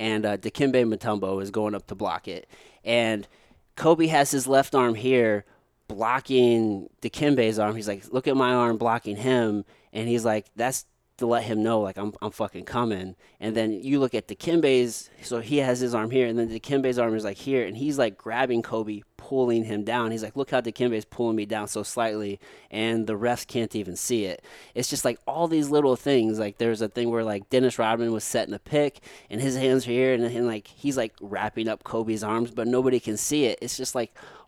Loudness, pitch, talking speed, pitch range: -25 LUFS, 115 Hz, 220 wpm, 110-130 Hz